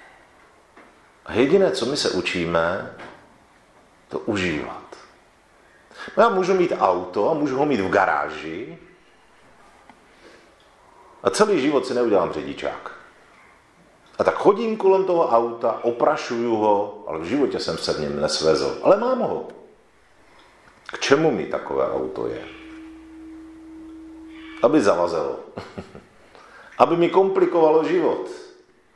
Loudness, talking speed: -21 LUFS, 115 wpm